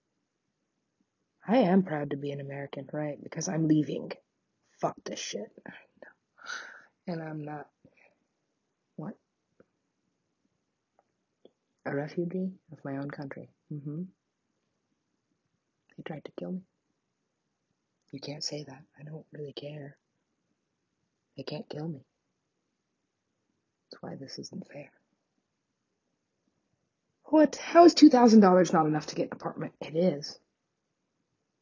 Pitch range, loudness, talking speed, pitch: 145-185 Hz, -27 LUFS, 115 wpm, 155 Hz